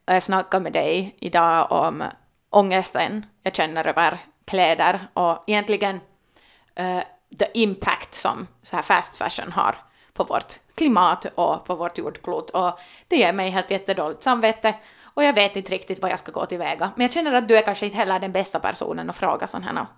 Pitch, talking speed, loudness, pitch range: 190 Hz, 190 wpm, -22 LUFS, 180-215 Hz